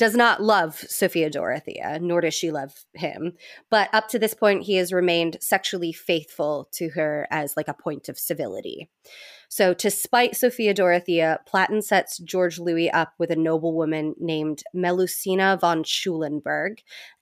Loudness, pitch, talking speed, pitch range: -23 LUFS, 175 Hz, 160 wpm, 160-195 Hz